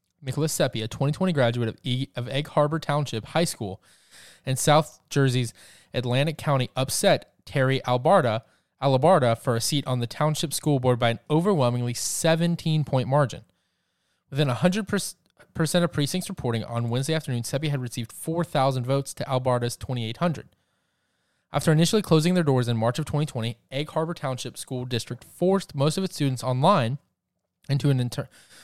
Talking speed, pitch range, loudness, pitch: 160 wpm, 125-155 Hz, -25 LUFS, 135 Hz